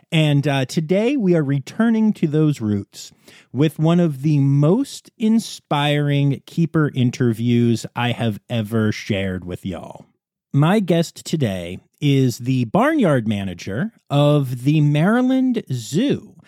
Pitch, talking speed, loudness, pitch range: 145 Hz, 125 wpm, -19 LUFS, 120-175 Hz